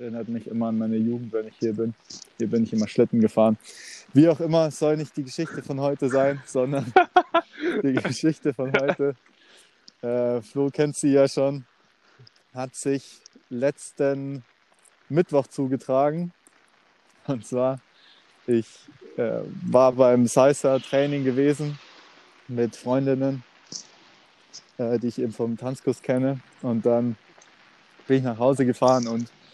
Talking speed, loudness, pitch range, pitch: 140 wpm, -24 LUFS, 120-140 Hz, 130 Hz